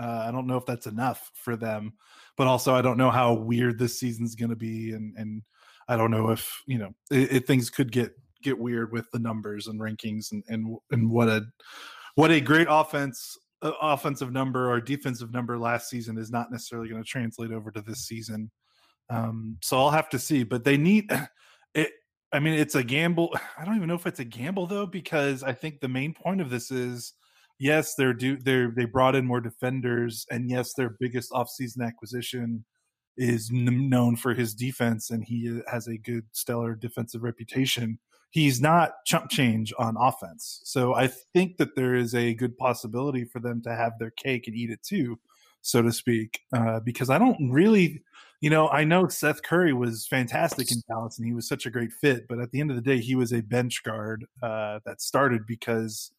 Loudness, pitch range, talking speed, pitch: -27 LUFS, 115-135 Hz, 210 wpm, 125 Hz